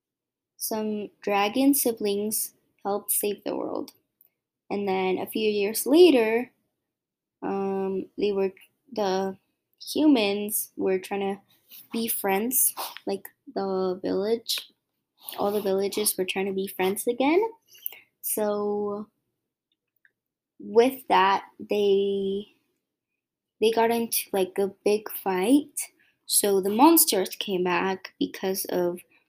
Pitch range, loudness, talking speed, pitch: 195-230 Hz, -25 LUFS, 110 wpm, 205 Hz